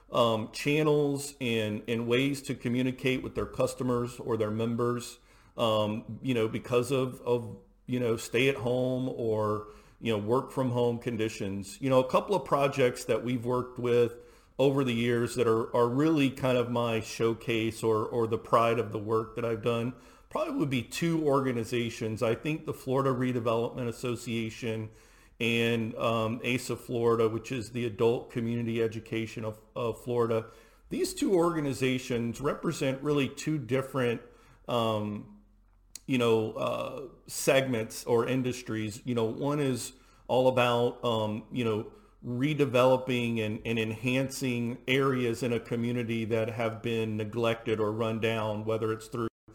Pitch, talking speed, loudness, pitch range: 120 Hz, 155 wpm, -30 LUFS, 115-130 Hz